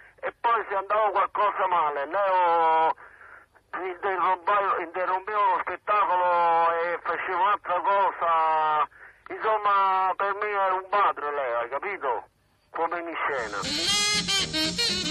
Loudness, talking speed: -25 LUFS, 105 wpm